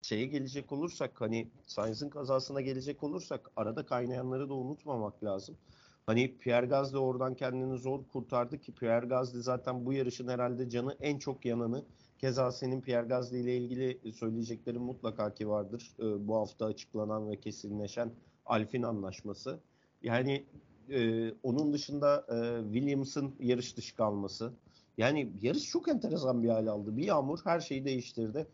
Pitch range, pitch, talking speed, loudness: 115-135 Hz, 125 Hz, 145 wpm, -35 LUFS